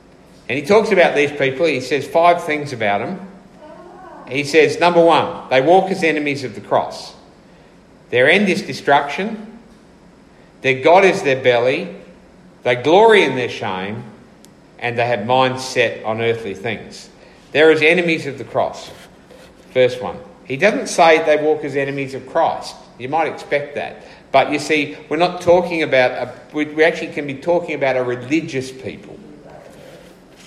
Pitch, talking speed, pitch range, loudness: 150 Hz, 165 wpm, 130-175 Hz, -16 LUFS